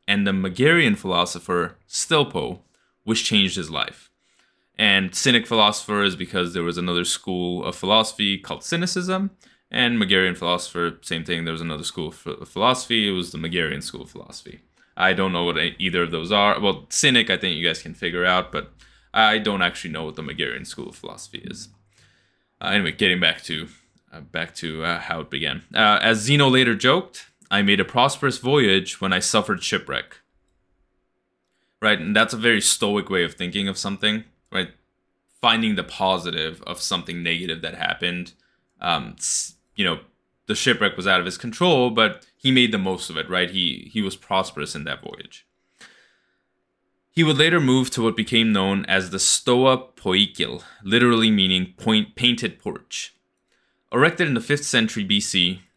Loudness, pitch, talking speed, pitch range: -21 LUFS, 100 Hz, 175 wpm, 90-120 Hz